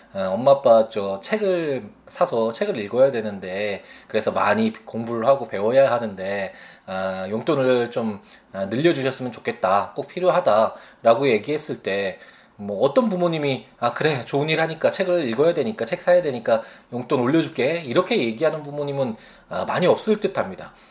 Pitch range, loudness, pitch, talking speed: 115-175 Hz, -22 LUFS, 140 Hz, 335 characters per minute